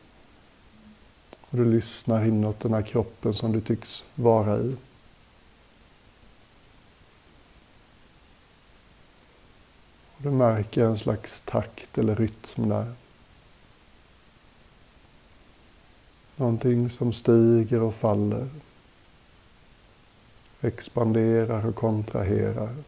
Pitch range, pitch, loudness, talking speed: 105-115 Hz, 115 Hz, -25 LUFS, 75 wpm